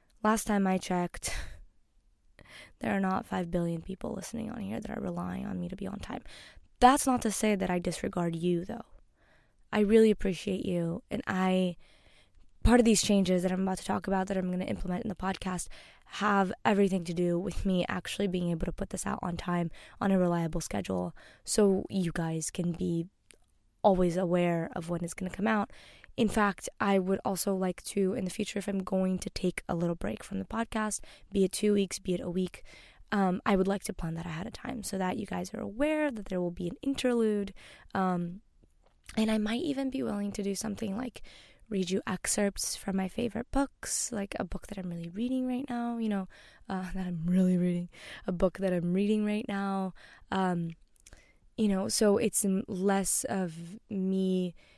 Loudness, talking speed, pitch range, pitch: -31 LUFS, 205 wpm, 180-210 Hz, 190 Hz